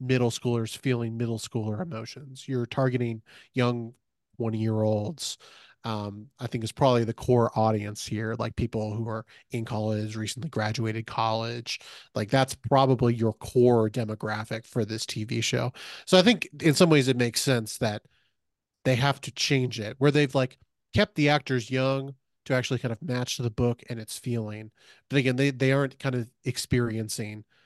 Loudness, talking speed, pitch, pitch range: -27 LUFS, 175 wpm, 120 Hz, 110-130 Hz